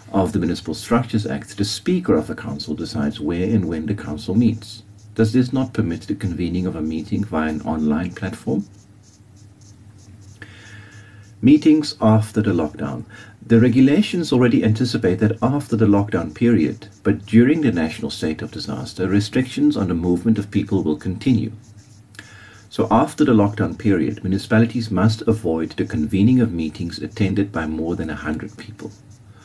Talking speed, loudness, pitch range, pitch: 155 wpm, -20 LUFS, 95-115 Hz, 105 Hz